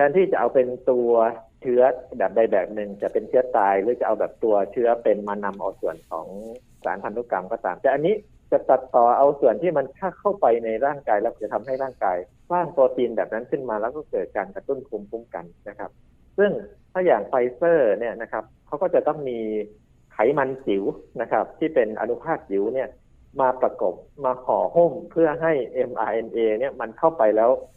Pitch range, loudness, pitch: 110-160 Hz, -23 LUFS, 125 Hz